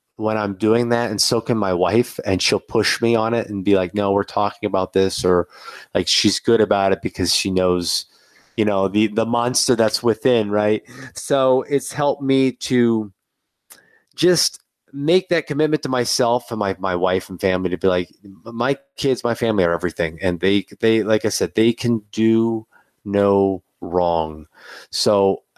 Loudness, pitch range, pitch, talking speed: -19 LUFS, 95-120 Hz, 110 Hz, 185 wpm